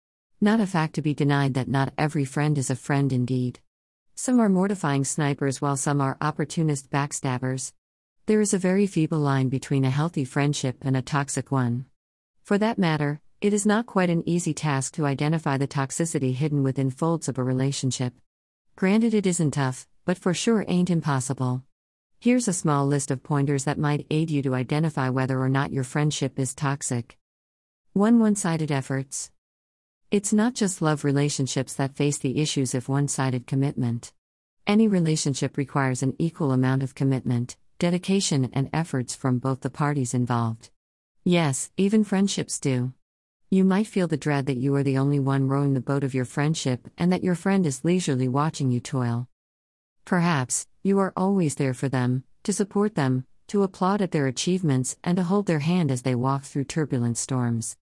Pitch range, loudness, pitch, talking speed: 130-165 Hz, -25 LUFS, 140 Hz, 180 wpm